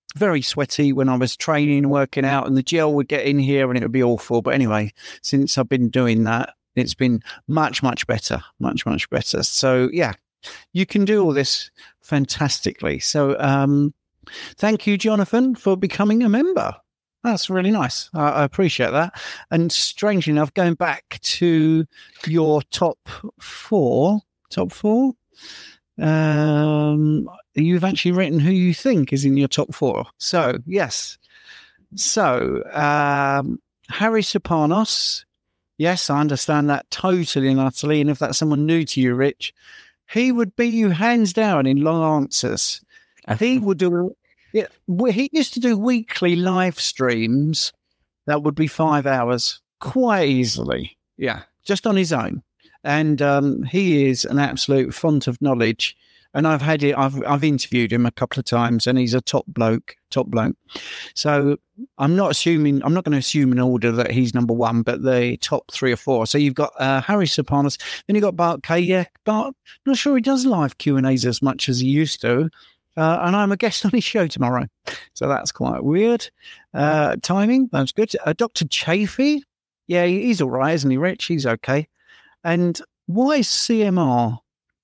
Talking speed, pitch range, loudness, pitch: 170 wpm, 135-195 Hz, -20 LUFS, 155 Hz